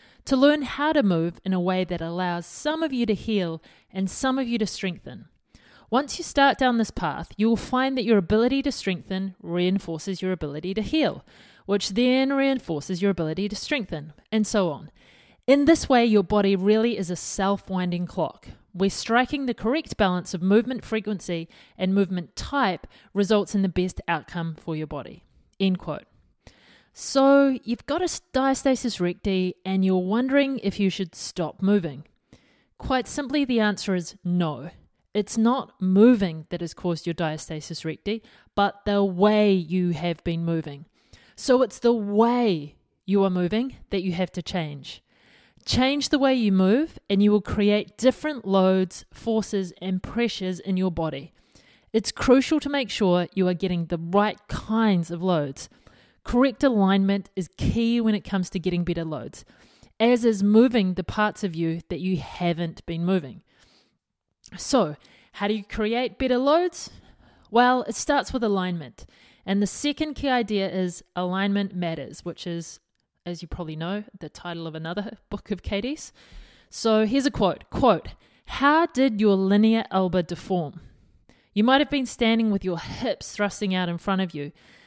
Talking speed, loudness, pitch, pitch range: 170 wpm, -24 LUFS, 200 Hz, 180-235 Hz